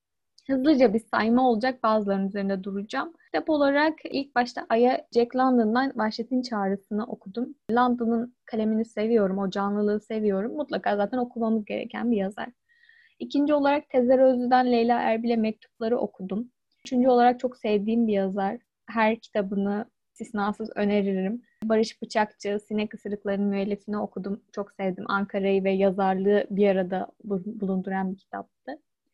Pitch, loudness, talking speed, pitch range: 220 Hz, -25 LUFS, 130 wpm, 200-250 Hz